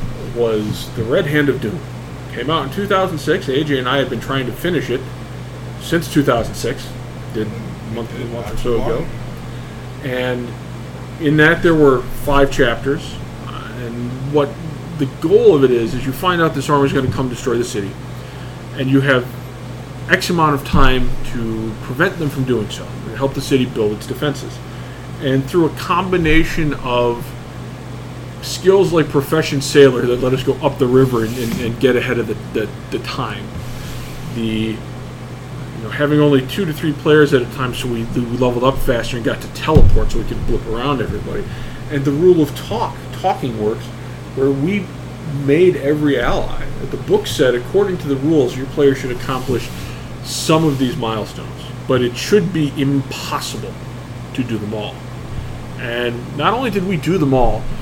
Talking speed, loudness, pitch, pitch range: 180 wpm, -17 LUFS, 130 Hz, 120-145 Hz